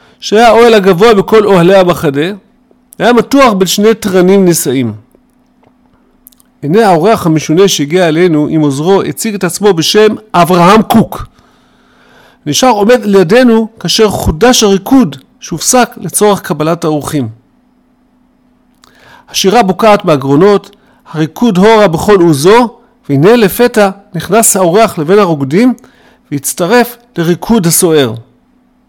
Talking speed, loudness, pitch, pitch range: 105 wpm, -8 LUFS, 200 Hz, 170-230 Hz